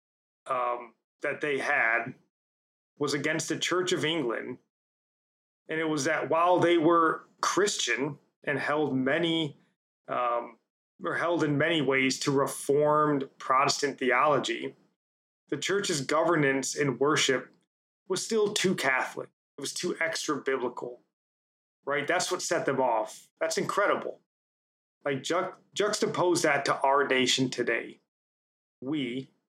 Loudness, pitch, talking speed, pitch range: -28 LUFS, 150 Hz, 125 wpm, 135-170 Hz